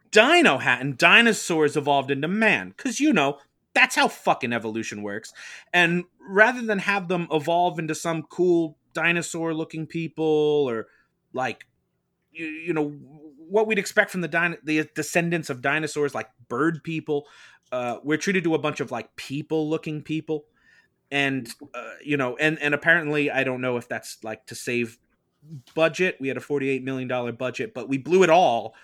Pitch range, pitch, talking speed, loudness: 135-170 Hz, 155 Hz, 170 wpm, -23 LUFS